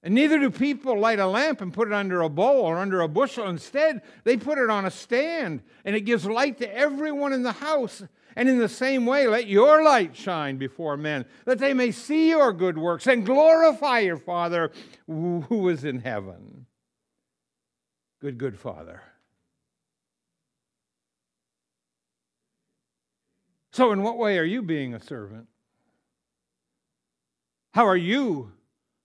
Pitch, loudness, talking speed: 200 Hz, -23 LUFS, 155 wpm